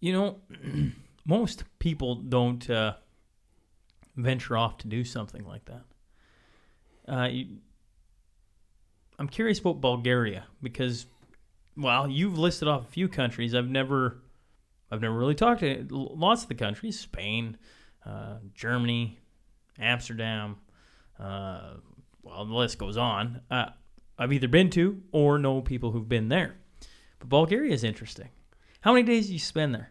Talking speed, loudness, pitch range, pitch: 140 wpm, -28 LUFS, 110-145 Hz, 125 Hz